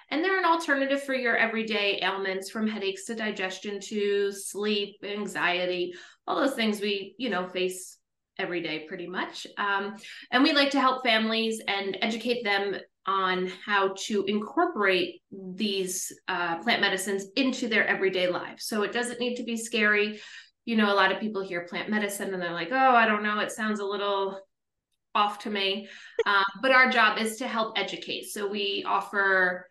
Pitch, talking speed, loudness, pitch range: 205 Hz, 180 wpm, -27 LUFS, 195-230 Hz